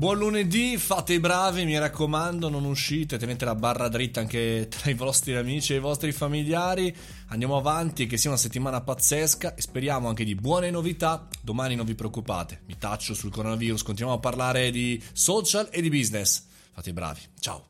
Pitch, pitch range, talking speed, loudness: 130 Hz, 115-160 Hz, 185 wpm, -26 LUFS